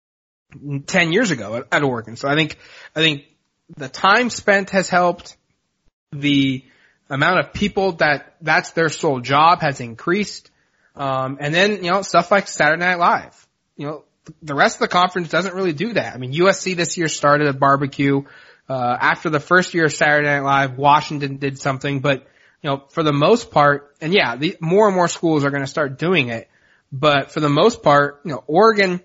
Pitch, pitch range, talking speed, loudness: 155 Hz, 140-180 Hz, 195 wpm, -18 LUFS